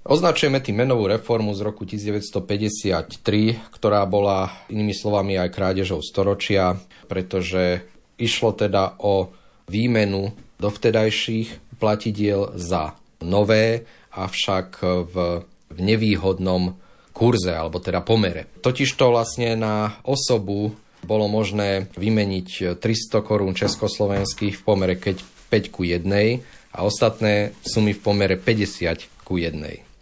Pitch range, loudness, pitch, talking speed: 95-110 Hz, -22 LUFS, 105 Hz, 110 wpm